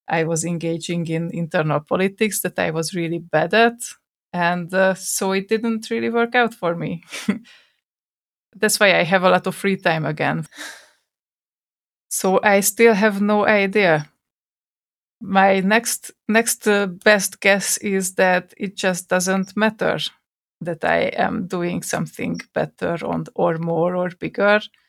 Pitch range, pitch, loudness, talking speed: 175-210 Hz, 190 Hz, -19 LUFS, 145 wpm